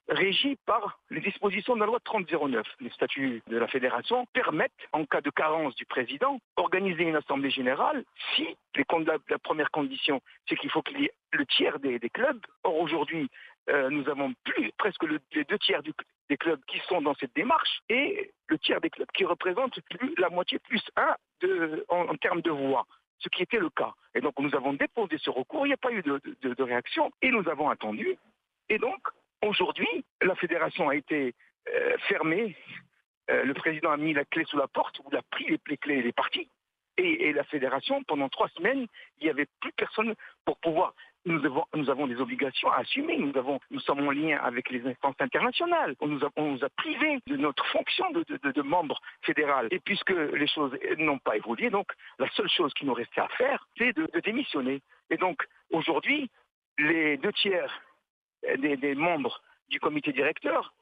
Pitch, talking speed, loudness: 220 Hz, 205 wpm, -29 LUFS